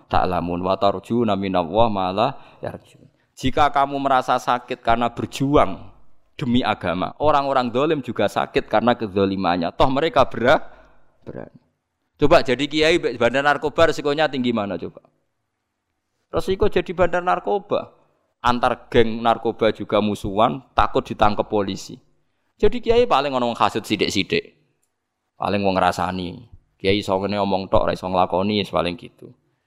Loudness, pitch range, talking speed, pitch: -20 LUFS, 100-135 Hz, 125 wpm, 115 Hz